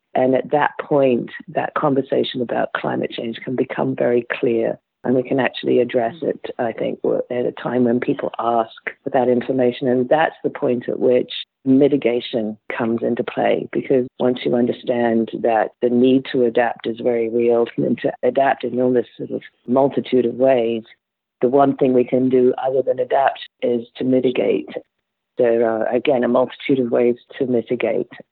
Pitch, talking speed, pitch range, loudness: 125 Hz, 180 wpm, 120-130 Hz, -19 LUFS